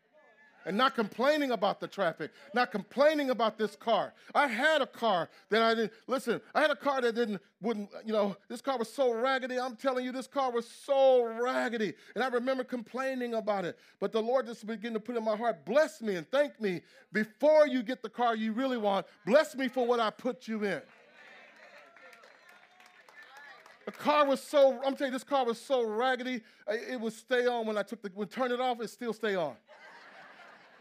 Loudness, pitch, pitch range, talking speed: -31 LUFS, 245 Hz, 220-265 Hz, 205 wpm